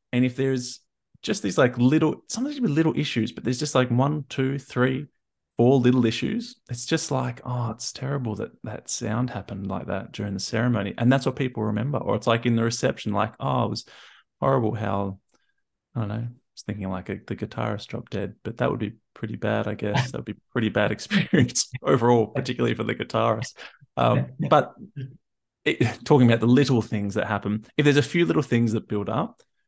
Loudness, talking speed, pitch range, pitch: -24 LUFS, 210 wpm, 110-135 Hz, 125 Hz